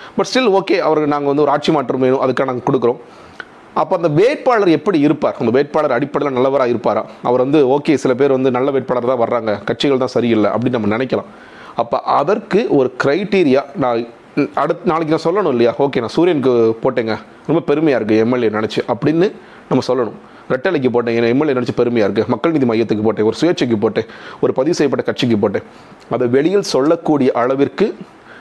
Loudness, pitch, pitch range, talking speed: -15 LUFS, 130 Hz, 115-145 Hz, 175 wpm